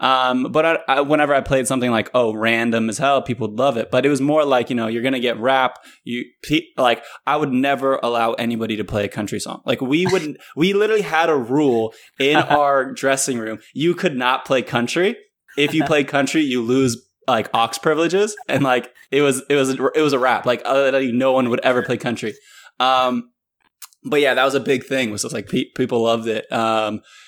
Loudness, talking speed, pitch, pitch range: -19 LUFS, 220 wpm, 130 Hz, 120-145 Hz